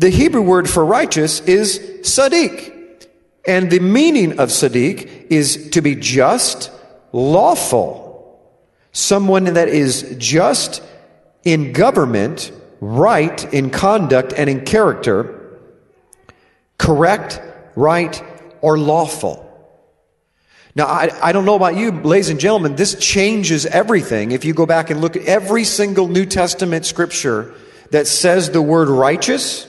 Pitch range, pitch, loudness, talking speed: 155-195 Hz, 175 Hz, -14 LUFS, 125 wpm